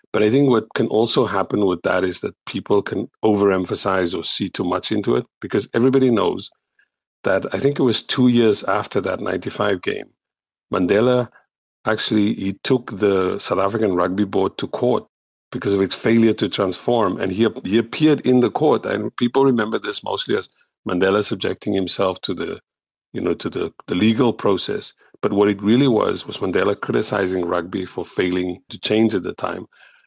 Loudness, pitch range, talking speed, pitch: -20 LUFS, 100-125 Hz, 185 wpm, 110 Hz